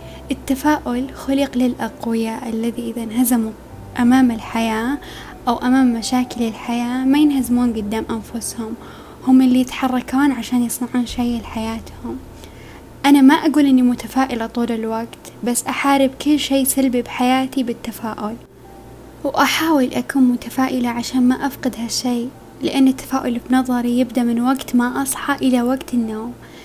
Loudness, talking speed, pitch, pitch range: -18 LUFS, 125 wpm, 250 Hz, 235-265 Hz